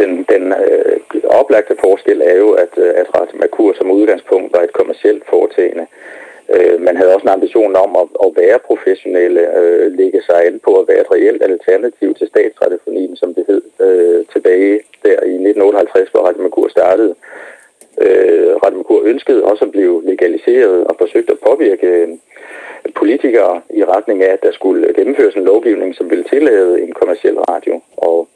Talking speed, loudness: 175 wpm, -11 LUFS